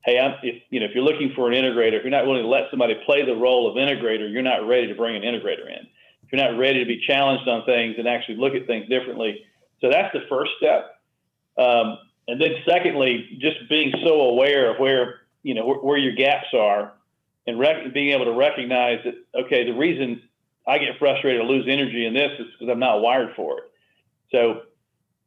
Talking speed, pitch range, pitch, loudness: 225 wpm, 120-140 Hz, 130 Hz, -21 LUFS